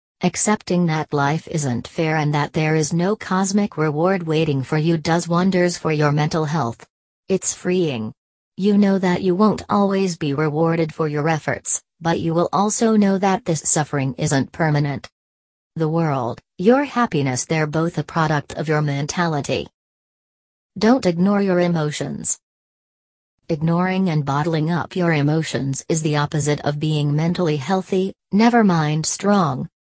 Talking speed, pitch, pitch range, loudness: 150 wpm, 160 Hz, 150-180 Hz, -19 LUFS